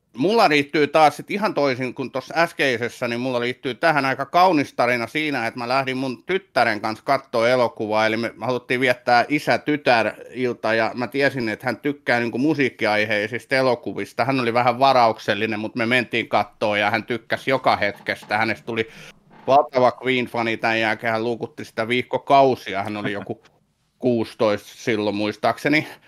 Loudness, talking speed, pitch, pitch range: -21 LUFS, 155 wpm, 125 Hz, 115-135 Hz